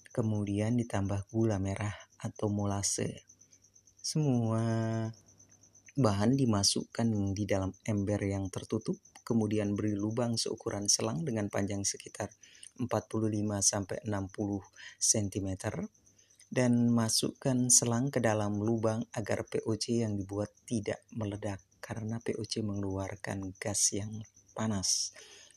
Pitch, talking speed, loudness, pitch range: 105 Hz, 100 wpm, -32 LUFS, 100-115 Hz